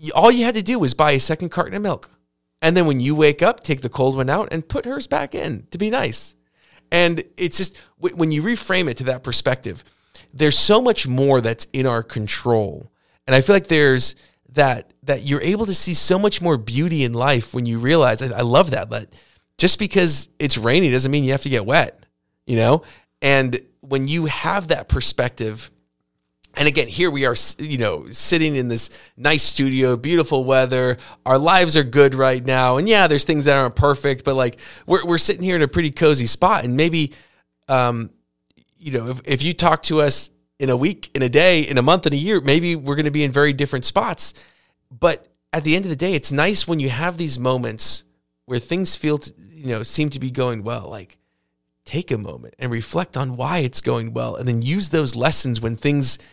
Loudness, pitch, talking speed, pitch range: -18 LUFS, 140 Hz, 215 wpm, 125-160 Hz